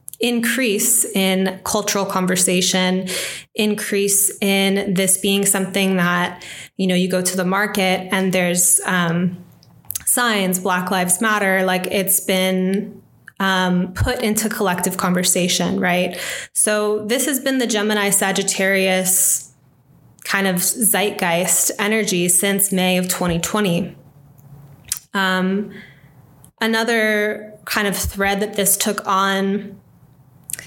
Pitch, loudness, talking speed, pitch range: 190 Hz, -17 LUFS, 110 wpm, 180-205 Hz